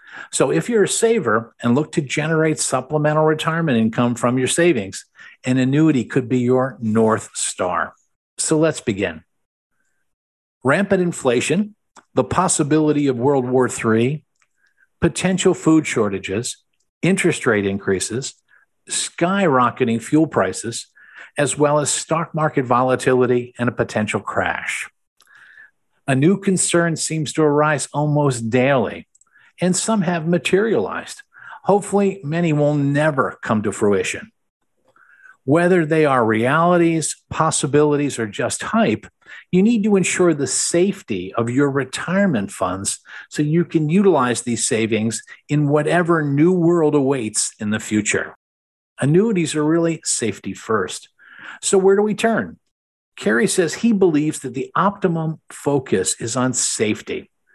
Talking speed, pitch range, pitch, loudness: 130 wpm, 125-170 Hz, 150 Hz, -18 LUFS